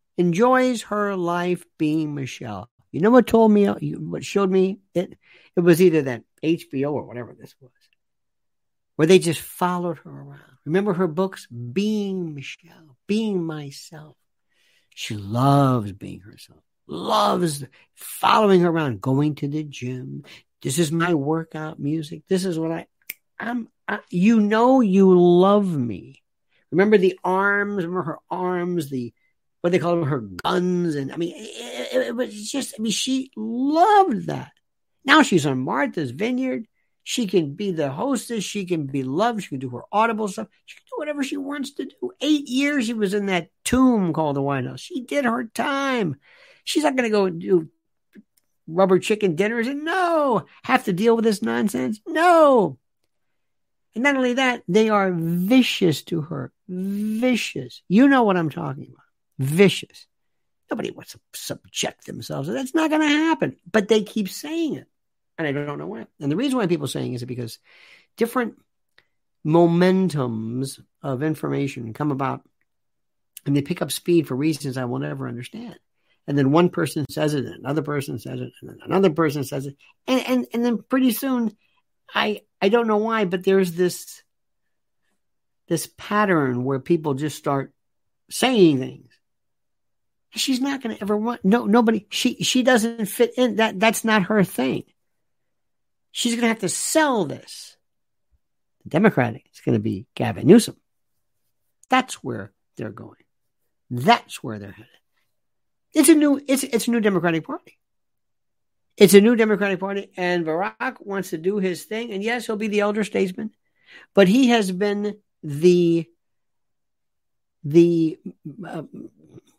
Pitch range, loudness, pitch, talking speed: 145-230 Hz, -21 LUFS, 185 Hz, 165 wpm